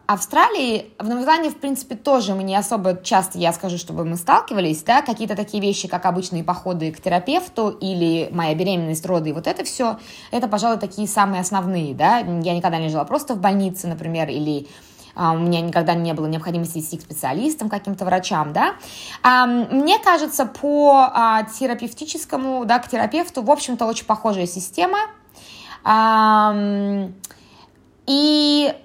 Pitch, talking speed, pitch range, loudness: 205 Hz, 150 wpm, 175-255 Hz, -19 LUFS